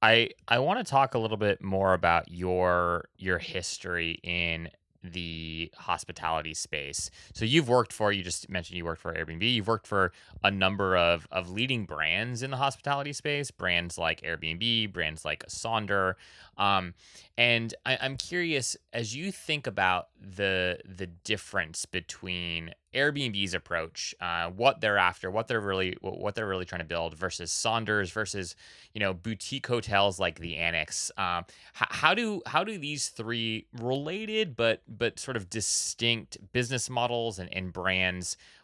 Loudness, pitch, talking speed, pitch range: -29 LUFS, 100 Hz, 160 wpm, 85-115 Hz